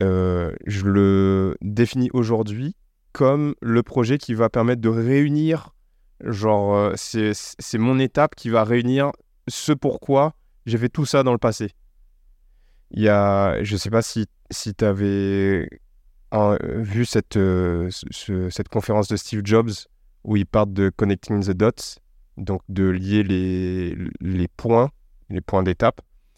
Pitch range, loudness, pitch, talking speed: 95-120 Hz, -21 LUFS, 105 Hz, 150 wpm